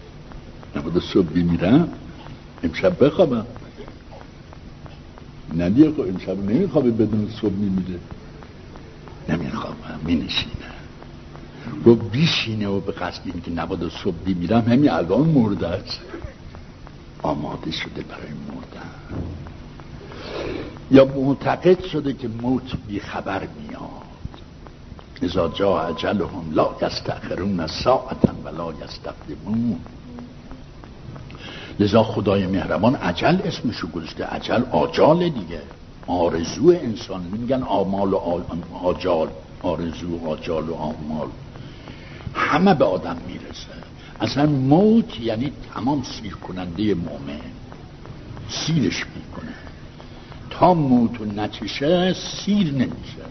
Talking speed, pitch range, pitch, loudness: 95 wpm, 85-130 Hz, 105 Hz, -21 LUFS